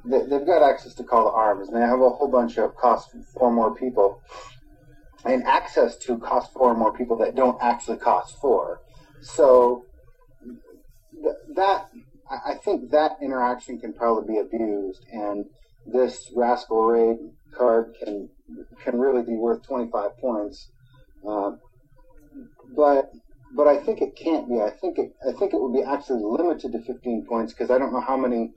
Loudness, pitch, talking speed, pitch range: -23 LUFS, 120 Hz, 165 wpm, 115-130 Hz